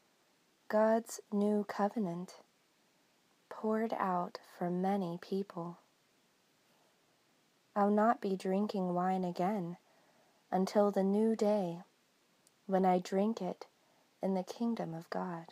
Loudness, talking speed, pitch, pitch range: -35 LUFS, 105 wpm, 195 Hz, 180-210 Hz